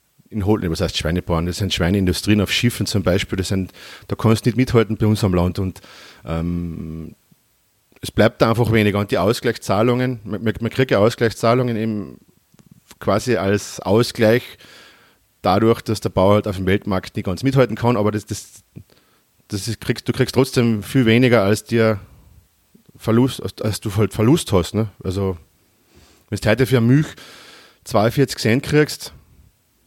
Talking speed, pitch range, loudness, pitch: 165 wpm, 95-120 Hz, -19 LUFS, 110 Hz